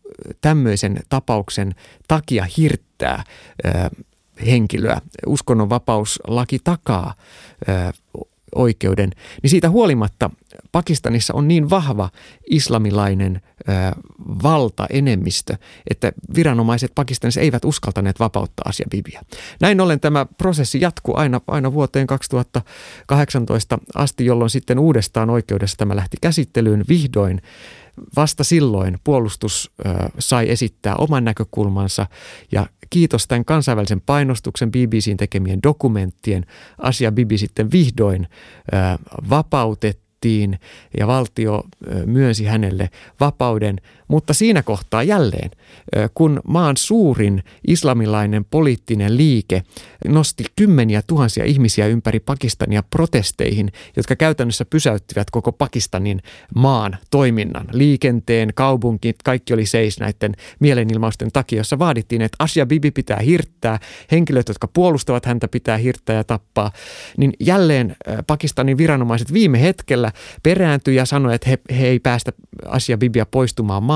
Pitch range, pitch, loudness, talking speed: 105-145 Hz, 120 Hz, -18 LUFS, 110 wpm